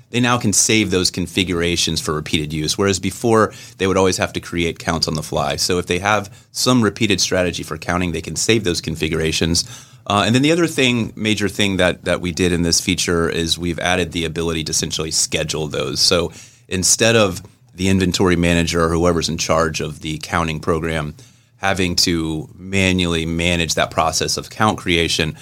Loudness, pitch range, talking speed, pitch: -18 LUFS, 80-100 Hz, 195 wpm, 90 Hz